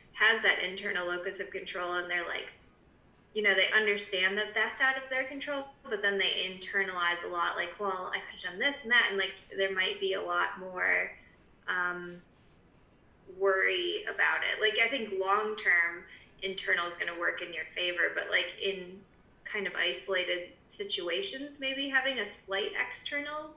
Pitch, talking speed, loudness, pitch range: 195 Hz, 180 wpm, -30 LUFS, 185-260 Hz